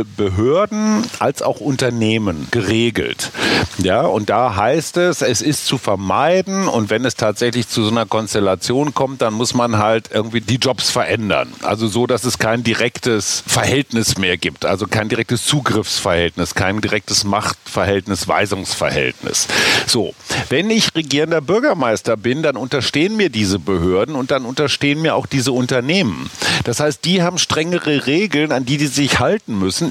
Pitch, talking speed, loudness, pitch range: 120 Hz, 155 wpm, -16 LUFS, 105-145 Hz